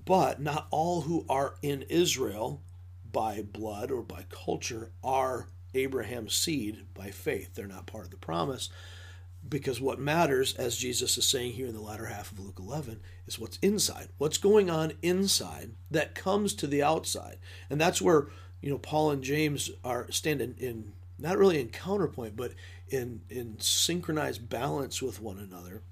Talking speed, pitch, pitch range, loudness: 170 wpm, 110 Hz, 90-140 Hz, -30 LUFS